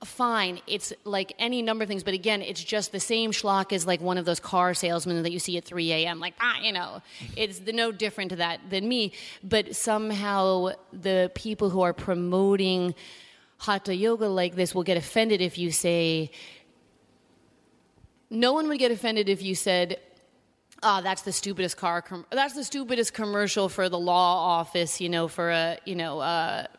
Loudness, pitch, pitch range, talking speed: -26 LUFS, 190 Hz, 180-215 Hz, 195 wpm